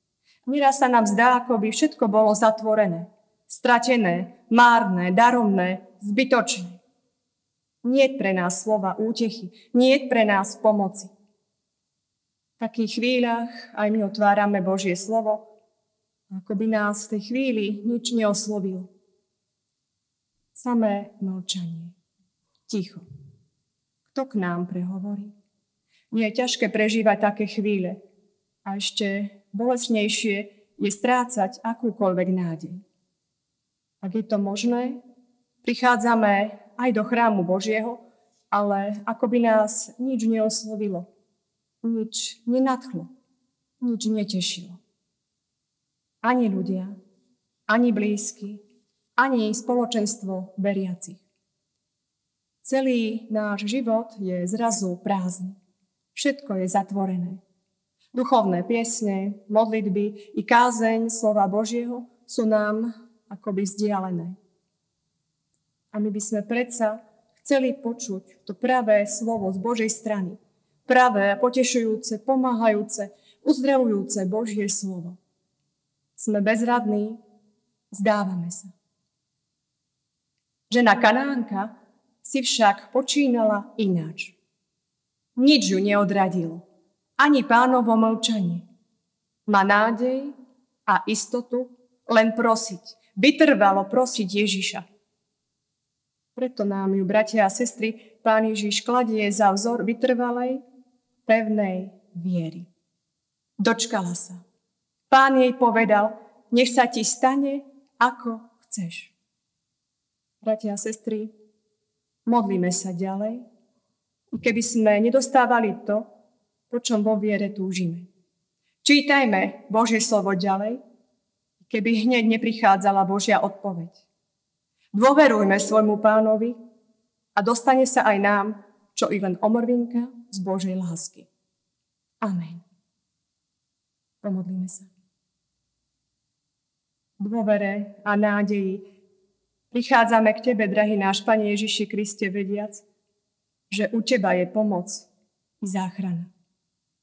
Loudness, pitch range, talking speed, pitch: -22 LUFS, 195-235 Hz, 95 wpm, 215 Hz